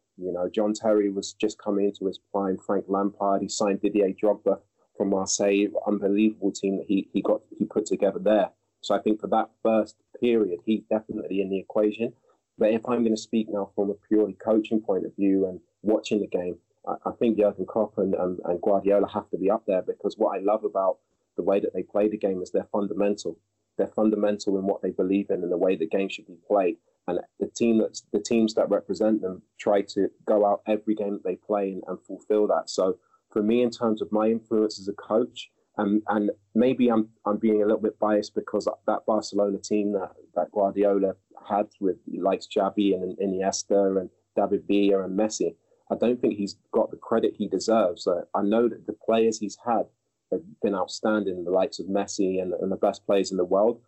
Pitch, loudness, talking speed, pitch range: 105 Hz, -26 LUFS, 220 wpm, 100-110 Hz